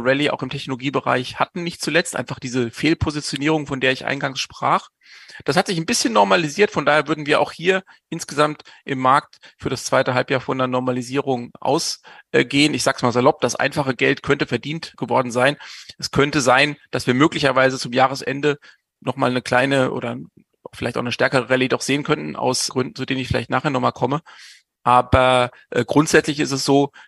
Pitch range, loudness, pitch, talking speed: 130-150 Hz, -19 LUFS, 135 Hz, 190 wpm